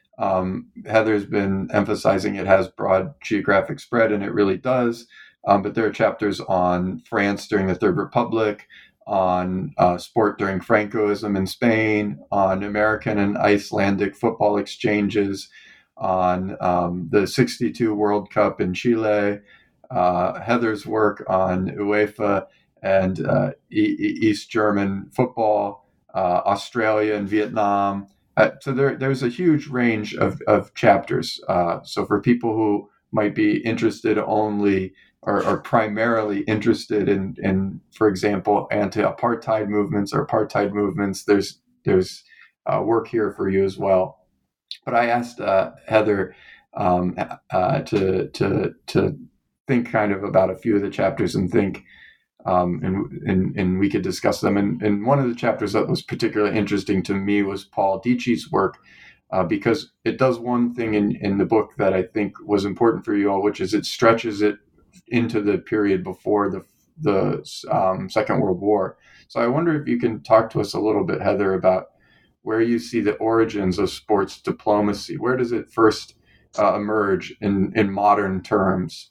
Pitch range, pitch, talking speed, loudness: 95-115 Hz, 105 Hz, 160 wpm, -21 LUFS